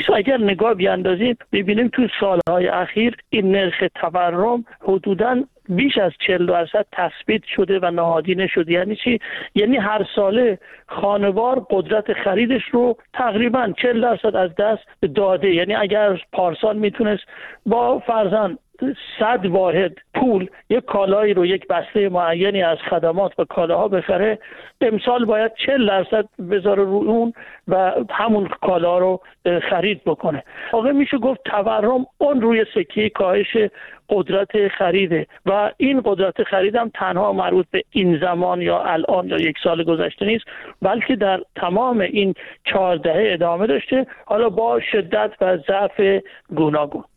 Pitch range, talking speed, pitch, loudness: 185-230 Hz, 140 wpm, 205 Hz, -19 LUFS